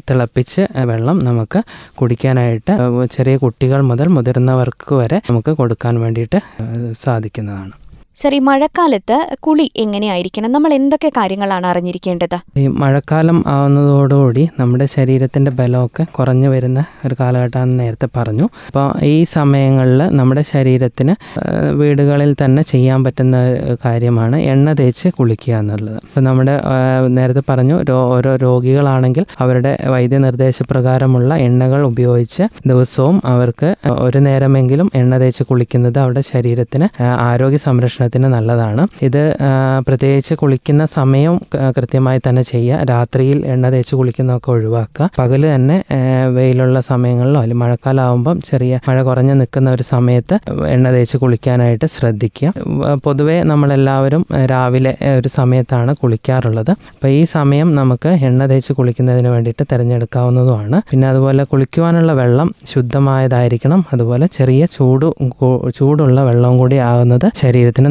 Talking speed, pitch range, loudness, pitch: 110 wpm, 125-145 Hz, -13 LUFS, 130 Hz